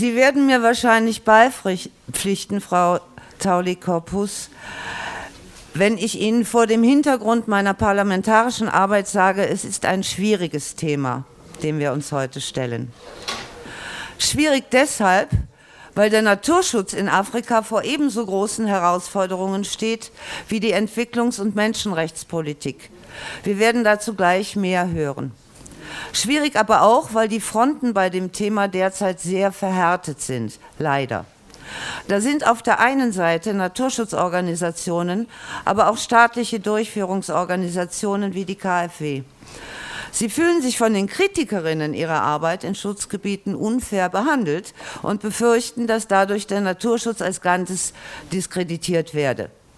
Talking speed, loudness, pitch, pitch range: 120 wpm, -20 LUFS, 200 Hz, 180-225 Hz